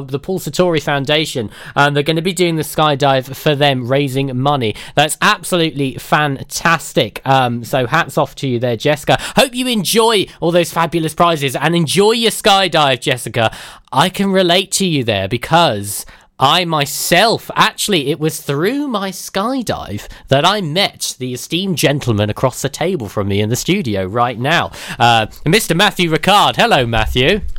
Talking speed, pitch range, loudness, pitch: 165 wpm, 130-175 Hz, -14 LUFS, 150 Hz